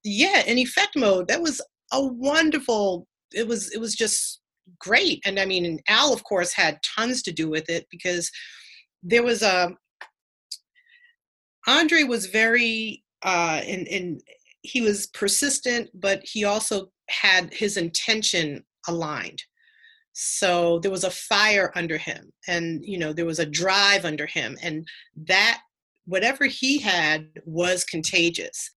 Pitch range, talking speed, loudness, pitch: 175-240 Hz, 145 wpm, -22 LUFS, 200 Hz